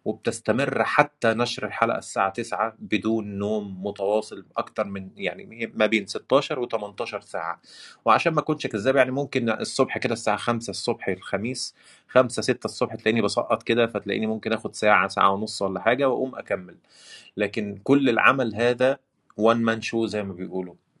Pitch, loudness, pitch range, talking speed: 110 Hz, -24 LUFS, 105-120 Hz, 160 wpm